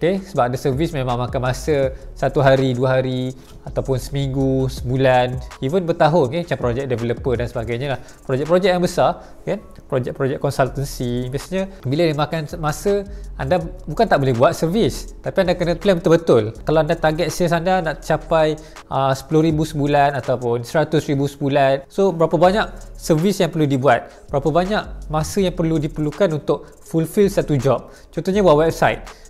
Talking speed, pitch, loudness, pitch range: 160 wpm, 150 Hz, -19 LUFS, 135-170 Hz